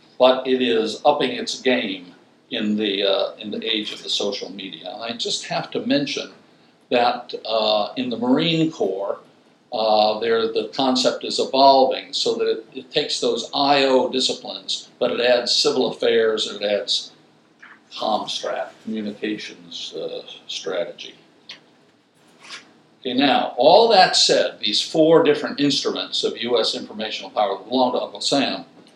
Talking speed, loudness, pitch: 145 wpm, -20 LUFS, 145 Hz